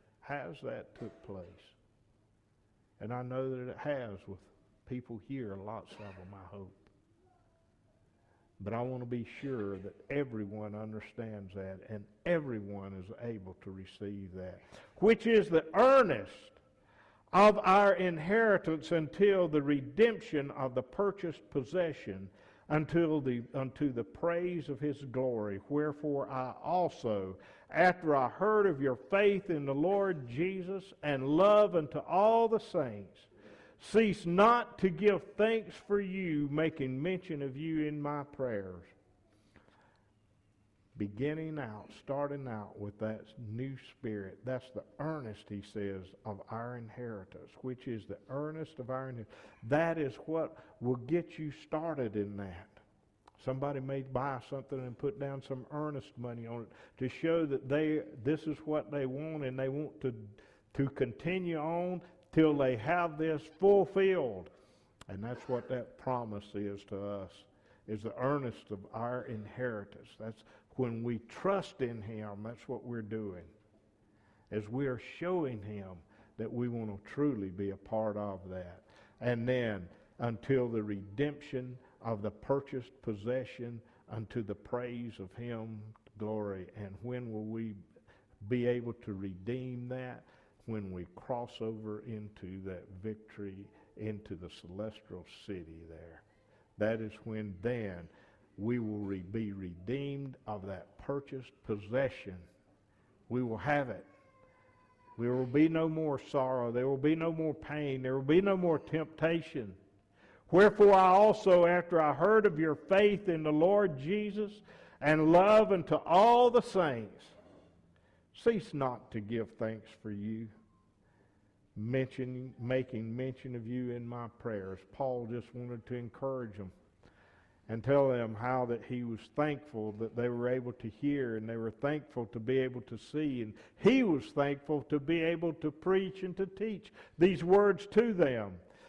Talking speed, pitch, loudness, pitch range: 150 wpm, 125 Hz, -33 LUFS, 105-150 Hz